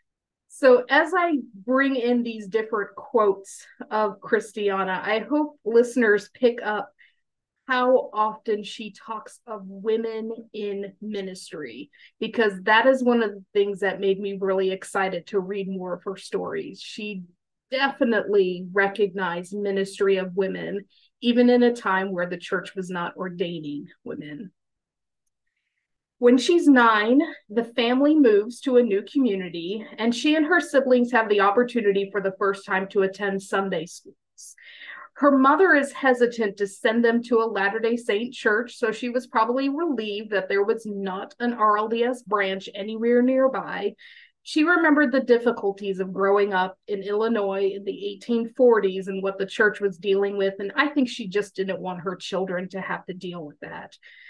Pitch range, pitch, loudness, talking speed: 195-245 Hz, 210 Hz, -23 LUFS, 160 wpm